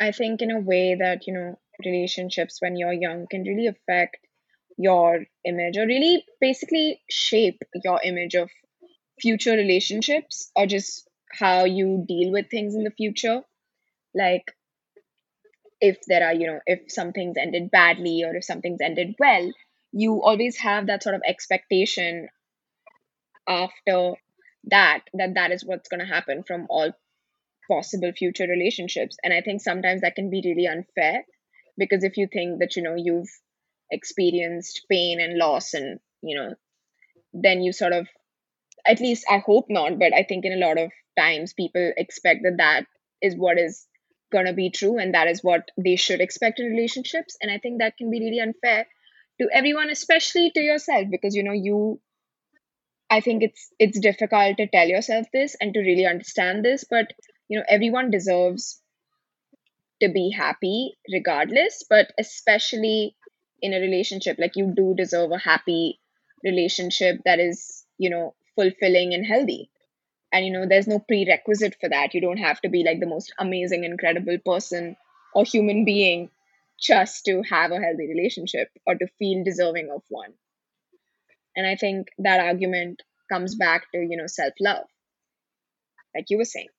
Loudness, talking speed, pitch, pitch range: -22 LUFS, 165 wpm, 190 Hz, 180-220 Hz